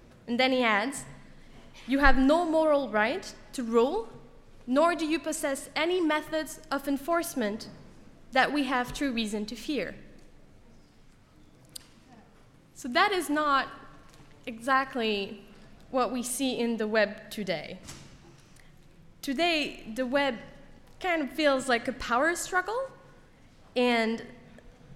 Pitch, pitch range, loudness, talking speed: 270 Hz, 235-310 Hz, -28 LUFS, 120 wpm